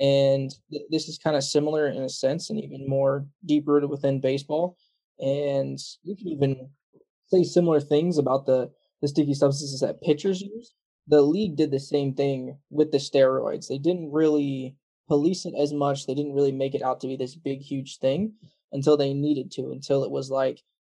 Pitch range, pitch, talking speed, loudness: 135-155 Hz, 145 Hz, 195 wpm, -25 LUFS